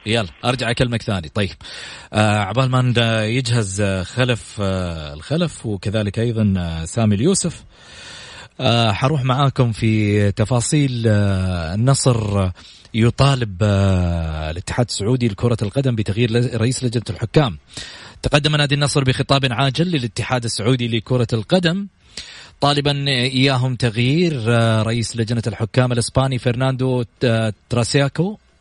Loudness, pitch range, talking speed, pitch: -18 LUFS, 105-130 Hz, 105 wpm, 120 Hz